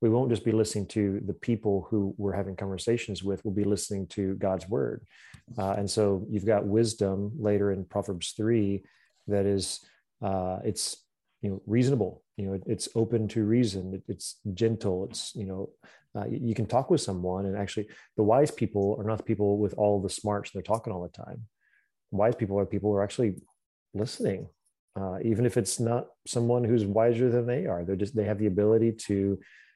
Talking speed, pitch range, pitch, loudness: 200 wpm, 100-115 Hz, 105 Hz, -29 LUFS